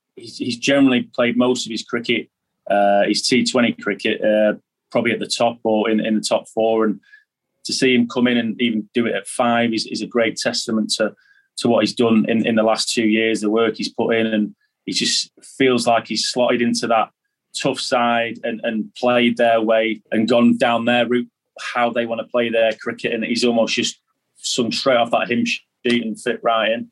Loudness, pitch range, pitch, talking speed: -19 LUFS, 110-120 Hz, 115 Hz, 220 wpm